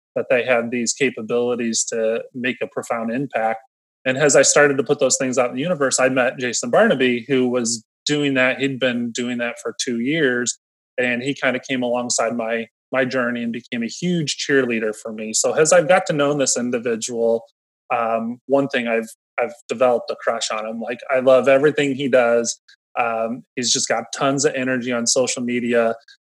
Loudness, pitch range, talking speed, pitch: -19 LUFS, 115-135 Hz, 200 wpm, 125 Hz